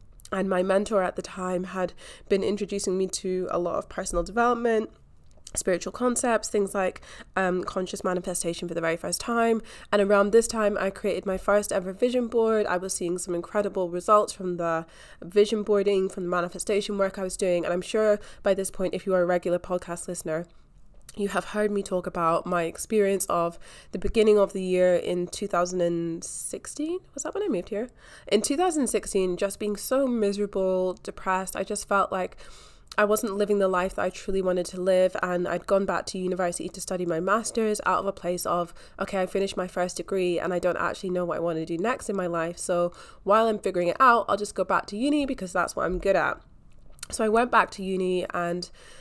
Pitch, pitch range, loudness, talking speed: 190 Hz, 180-205 Hz, -26 LUFS, 210 wpm